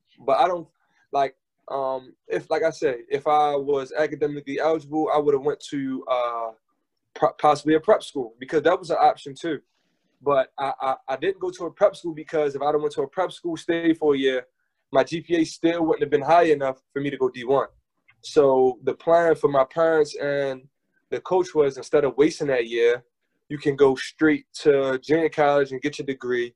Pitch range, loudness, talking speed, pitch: 140-180 Hz, -23 LUFS, 210 wpm, 155 Hz